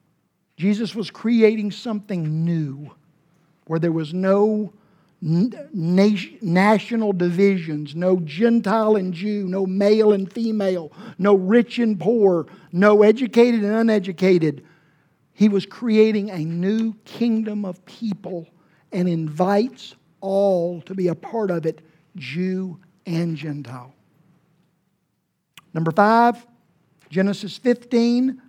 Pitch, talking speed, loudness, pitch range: 190 Hz, 110 wpm, -20 LUFS, 170-215 Hz